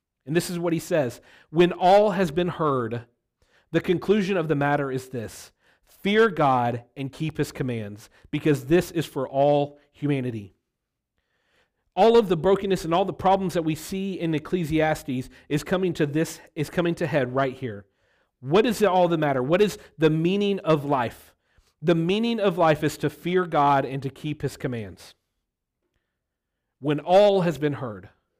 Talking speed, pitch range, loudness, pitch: 175 wpm, 135-180 Hz, -24 LUFS, 155 Hz